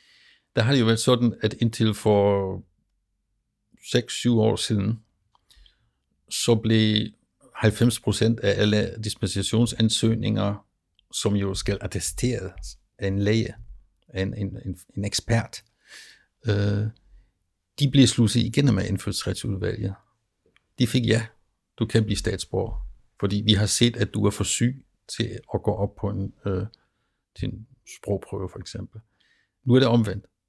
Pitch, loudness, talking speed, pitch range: 105 Hz, -24 LUFS, 135 wpm, 100-115 Hz